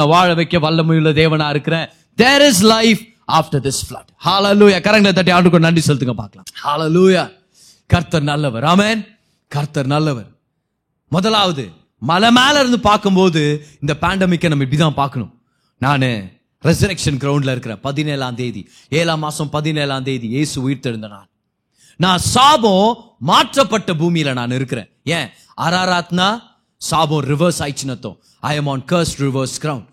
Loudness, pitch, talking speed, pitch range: -15 LUFS, 155 Hz, 135 wpm, 135-180 Hz